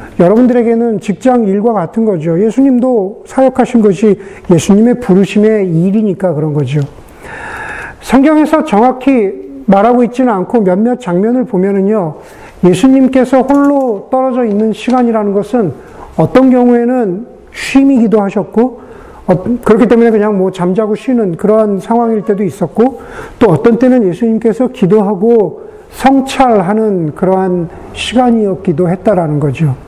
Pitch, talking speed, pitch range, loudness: 220 Hz, 310 characters per minute, 195-250 Hz, -10 LUFS